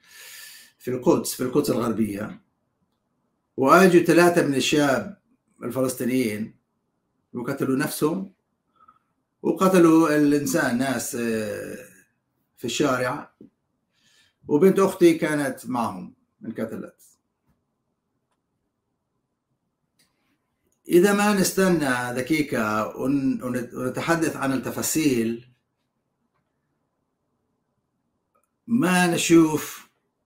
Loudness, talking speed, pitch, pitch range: -22 LUFS, 65 wpm, 150 Hz, 125-185 Hz